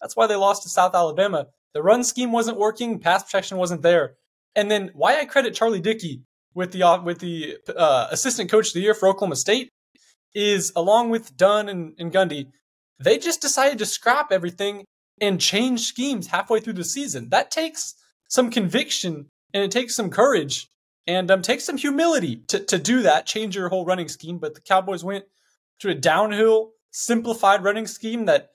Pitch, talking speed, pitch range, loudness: 205 Hz, 190 wpm, 185-235 Hz, -21 LUFS